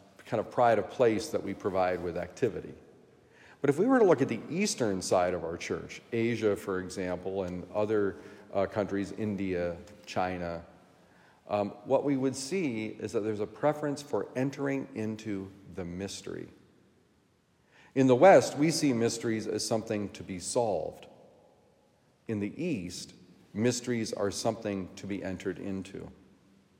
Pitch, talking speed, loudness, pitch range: 105 Hz, 150 wpm, -30 LUFS, 95-115 Hz